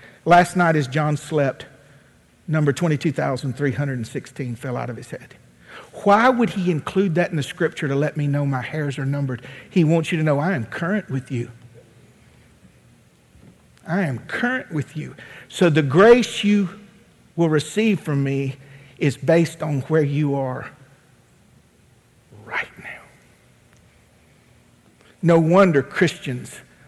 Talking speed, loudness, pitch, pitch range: 140 wpm, -20 LUFS, 150 Hz, 135-175 Hz